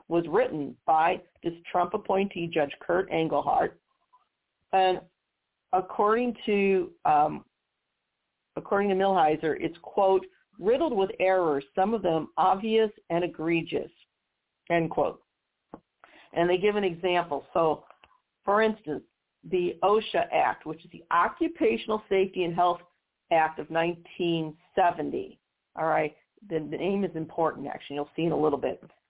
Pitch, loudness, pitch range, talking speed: 180 Hz, -27 LUFS, 160-205 Hz, 135 wpm